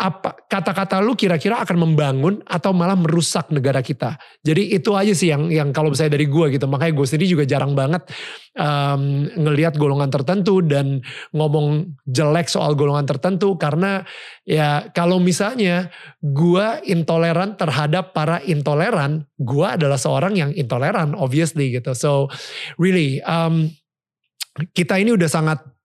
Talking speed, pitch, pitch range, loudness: 140 wpm, 160 Hz, 145-180 Hz, -19 LUFS